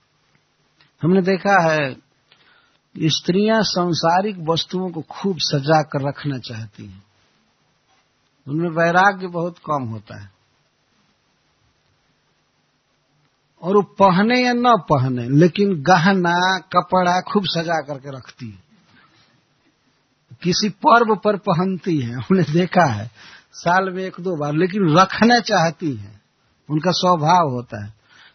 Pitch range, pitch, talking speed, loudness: 140-185 Hz, 170 Hz, 115 wpm, -18 LUFS